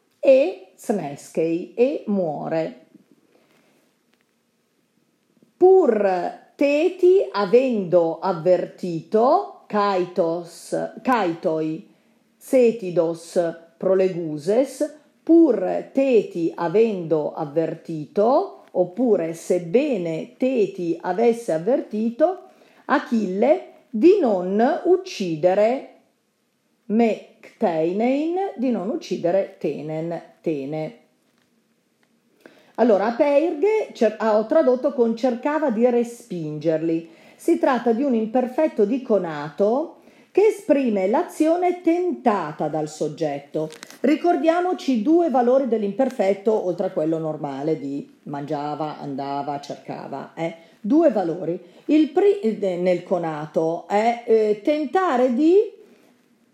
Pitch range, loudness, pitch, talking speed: 170-285 Hz, -21 LUFS, 220 Hz, 80 wpm